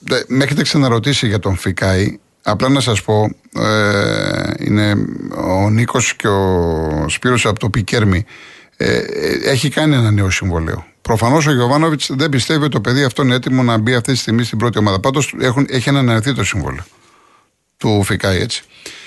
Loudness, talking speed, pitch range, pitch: -15 LUFS, 170 wpm, 100-135 Hz, 115 Hz